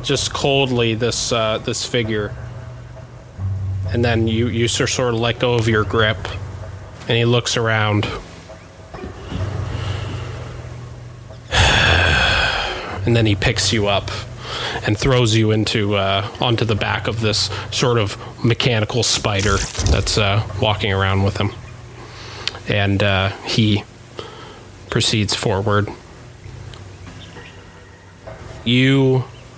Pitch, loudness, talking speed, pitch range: 110 Hz, -18 LUFS, 110 wpm, 100-120 Hz